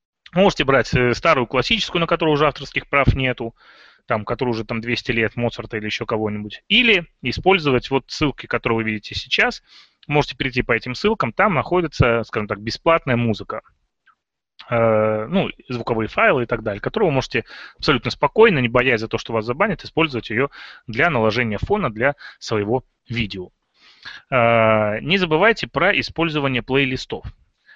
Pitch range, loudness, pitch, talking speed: 115-150 Hz, -19 LUFS, 125 Hz, 150 wpm